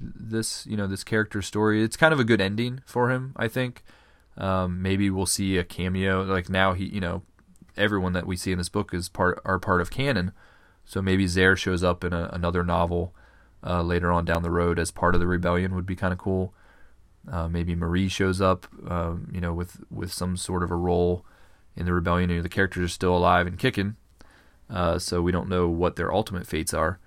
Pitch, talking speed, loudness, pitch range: 90 Hz, 225 wpm, -25 LUFS, 85-95 Hz